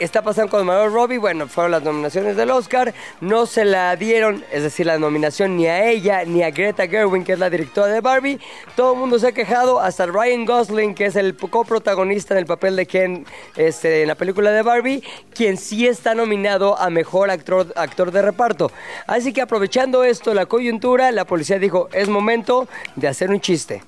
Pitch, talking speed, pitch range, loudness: 205 Hz, 205 wpm, 185-235 Hz, -18 LUFS